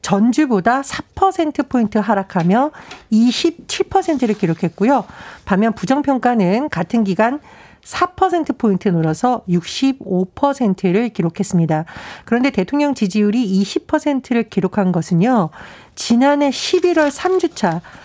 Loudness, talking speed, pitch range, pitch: -17 LUFS, 215 characters per minute, 195-285 Hz, 230 Hz